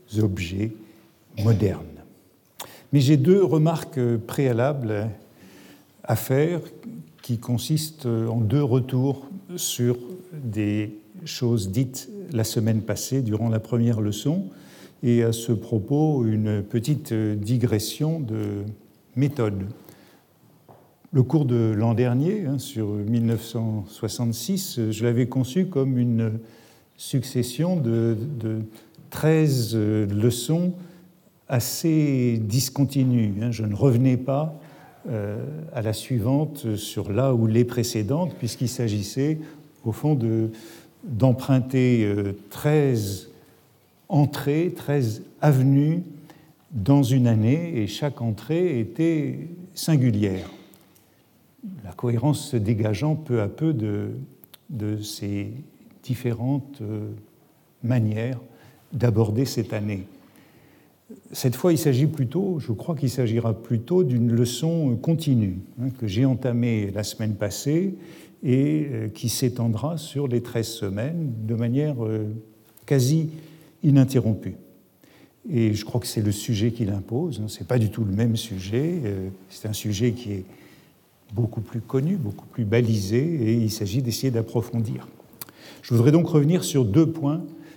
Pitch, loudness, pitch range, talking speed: 120 Hz, -24 LUFS, 110-150 Hz, 120 wpm